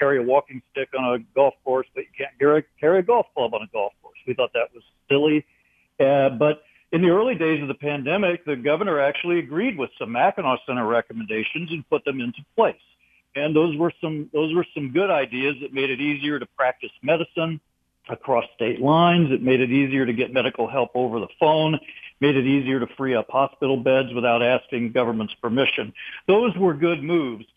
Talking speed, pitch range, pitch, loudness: 205 wpm, 130-160 Hz, 140 Hz, -22 LUFS